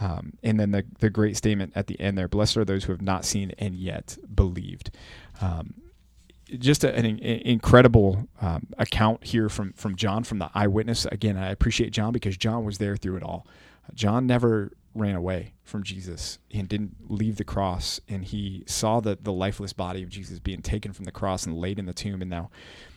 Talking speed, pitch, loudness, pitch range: 205 wpm, 100 Hz, -26 LUFS, 95-110 Hz